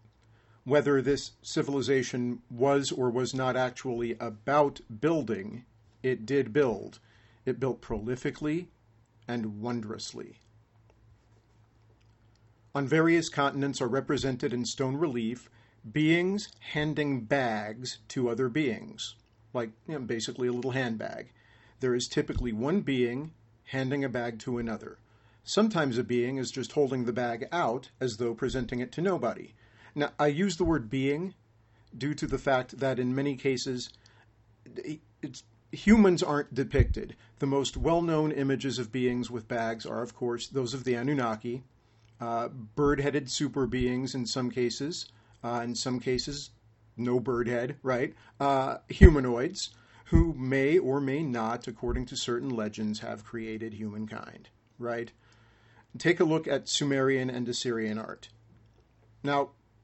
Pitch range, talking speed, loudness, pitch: 115-140 Hz, 140 wpm, -30 LUFS, 125 Hz